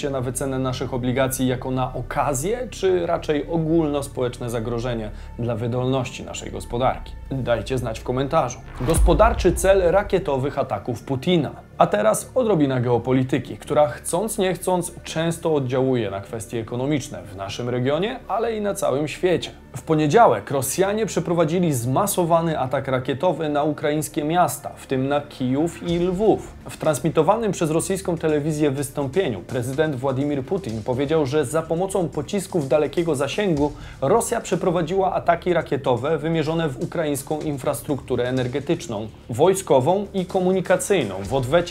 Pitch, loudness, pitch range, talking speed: 150 Hz, -22 LUFS, 130-175 Hz, 130 wpm